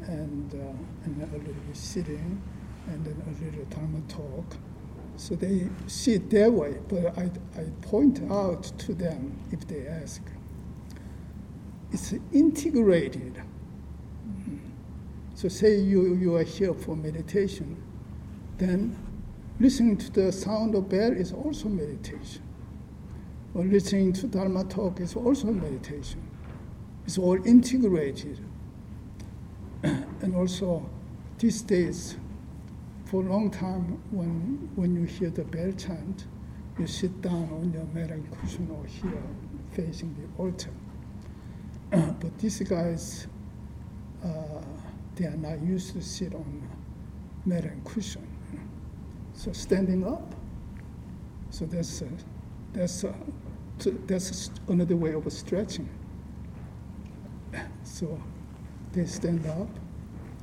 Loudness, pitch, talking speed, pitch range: -29 LUFS, 180 Hz, 115 wpm, 160-195 Hz